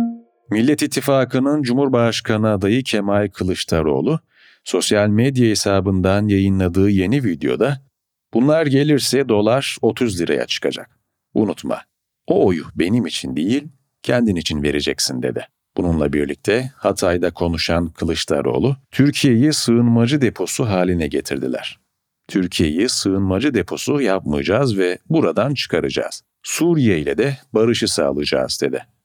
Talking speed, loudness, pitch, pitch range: 105 wpm, -18 LUFS, 110 Hz, 95-135 Hz